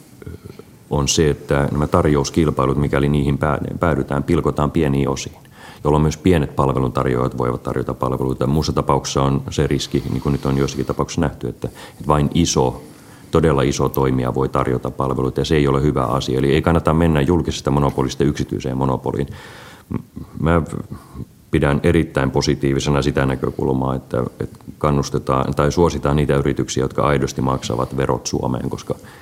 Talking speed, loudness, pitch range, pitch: 150 wpm, -19 LUFS, 65-75 Hz, 70 Hz